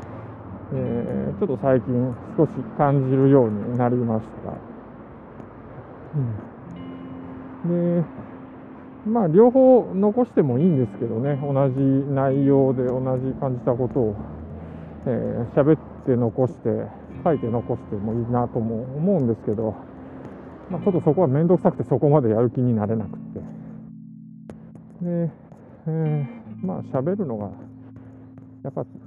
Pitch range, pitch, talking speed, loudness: 115-145 Hz, 130 Hz, 250 characters per minute, -22 LUFS